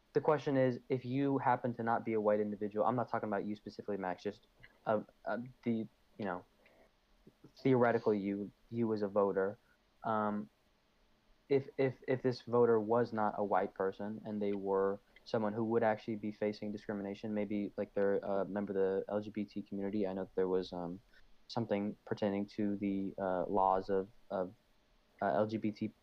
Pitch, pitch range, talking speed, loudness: 105 Hz, 100-115 Hz, 180 wpm, -36 LUFS